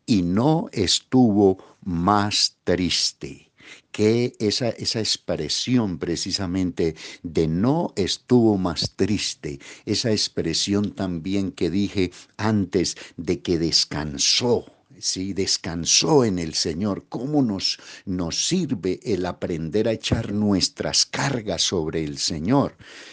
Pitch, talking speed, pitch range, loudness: 100 Hz, 110 wpm, 90-110 Hz, -22 LUFS